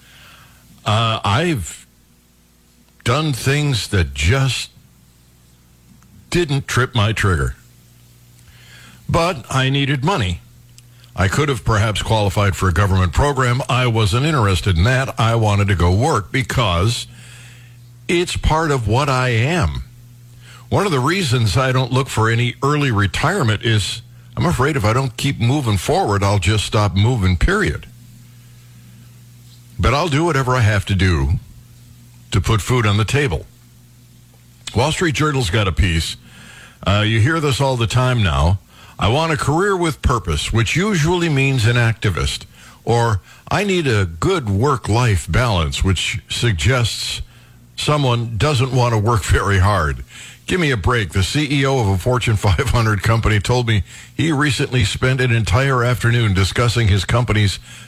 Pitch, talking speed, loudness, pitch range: 120 Hz, 150 wpm, -17 LUFS, 100-130 Hz